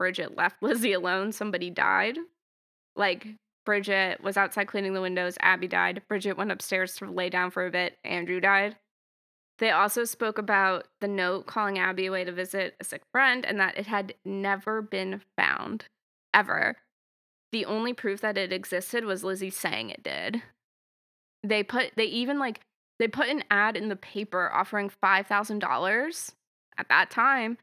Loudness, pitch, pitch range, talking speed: -27 LUFS, 200 Hz, 185-215 Hz, 165 wpm